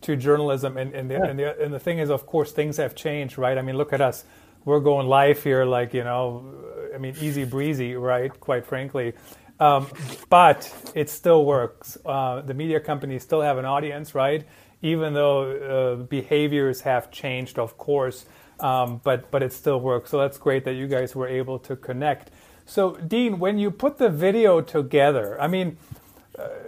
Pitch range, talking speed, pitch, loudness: 130-150 Hz, 190 wpm, 140 Hz, -23 LUFS